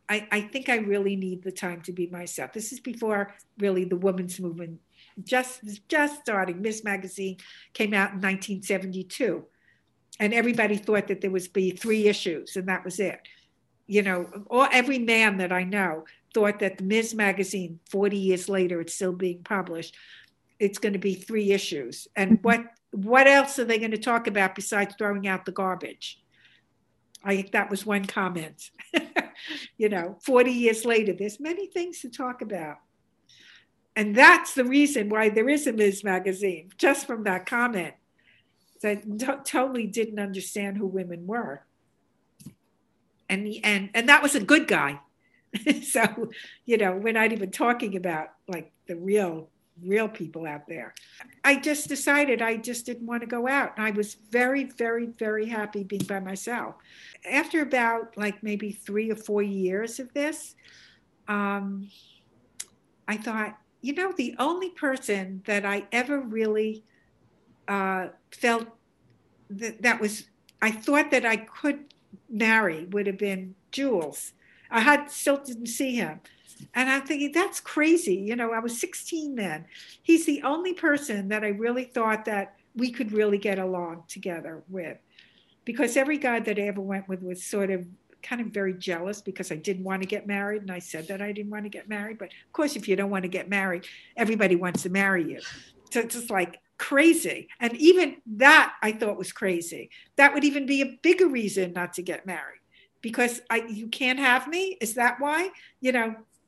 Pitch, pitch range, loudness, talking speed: 210 Hz, 195-245 Hz, -25 LUFS, 175 wpm